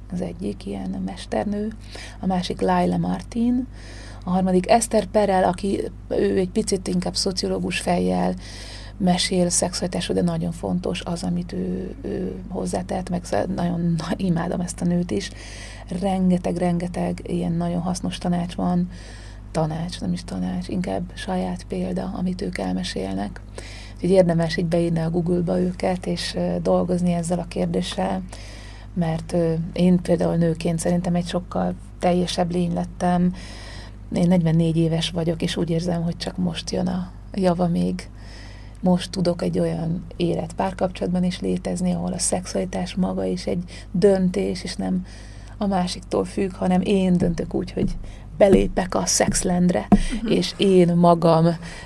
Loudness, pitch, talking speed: -23 LUFS, 170 Hz, 140 wpm